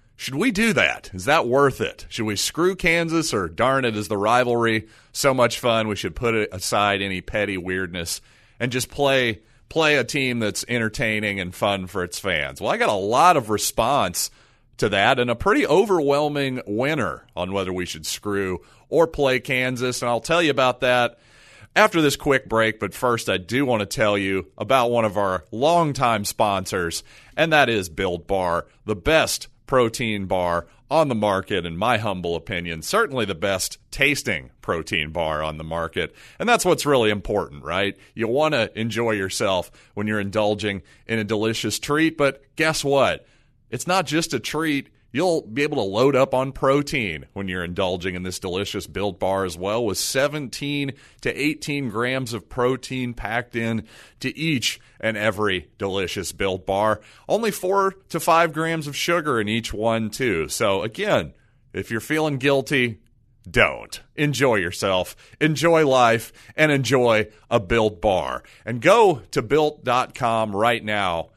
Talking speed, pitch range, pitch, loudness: 170 wpm, 100-140 Hz, 115 Hz, -22 LUFS